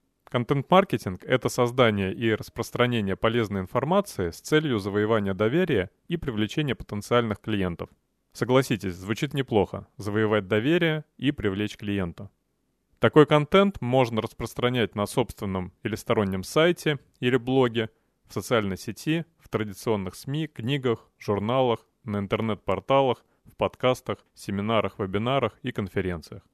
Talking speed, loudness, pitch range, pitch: 115 wpm, -26 LUFS, 105-130 Hz, 115 Hz